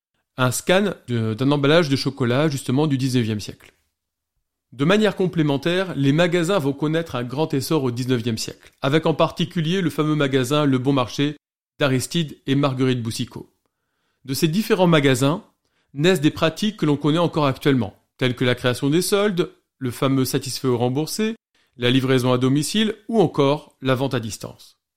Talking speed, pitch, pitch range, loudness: 165 wpm, 140 Hz, 130-165 Hz, -21 LUFS